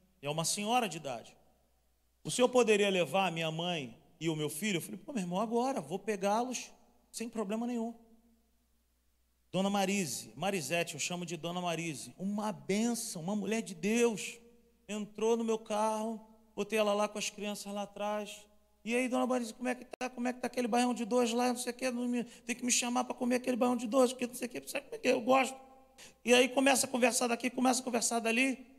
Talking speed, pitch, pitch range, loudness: 220 wpm, 225 Hz, 195-245 Hz, -33 LUFS